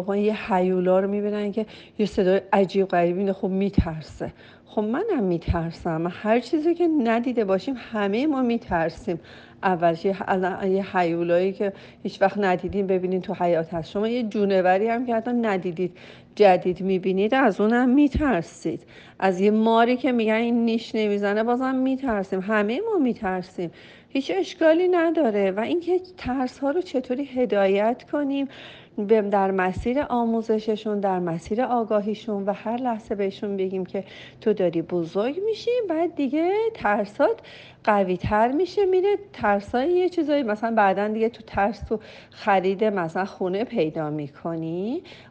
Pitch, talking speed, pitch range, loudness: 210 Hz, 145 wpm, 190-245 Hz, -23 LUFS